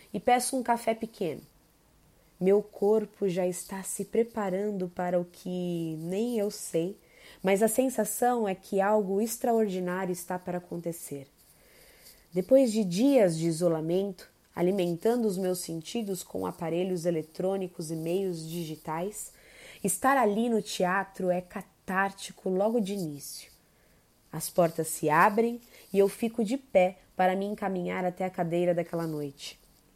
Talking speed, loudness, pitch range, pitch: 135 wpm, -29 LUFS, 175-210 Hz, 190 Hz